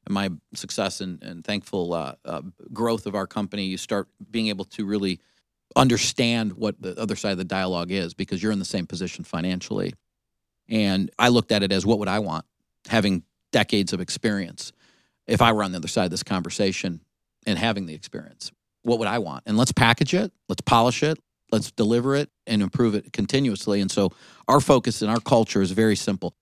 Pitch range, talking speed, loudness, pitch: 95-115 Hz, 200 wpm, -24 LUFS, 105 Hz